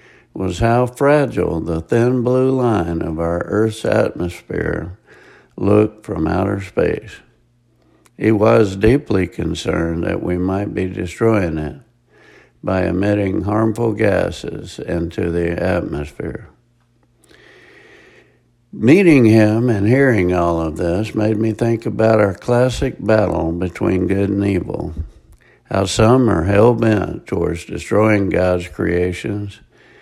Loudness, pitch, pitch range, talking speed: -17 LUFS, 105 Hz, 90-115 Hz, 120 wpm